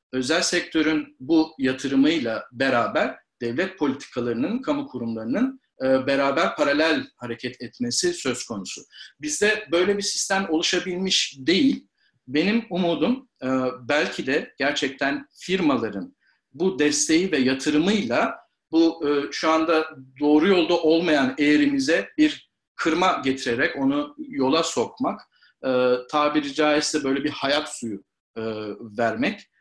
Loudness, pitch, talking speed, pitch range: -23 LUFS, 160 Hz, 105 wpm, 135-205 Hz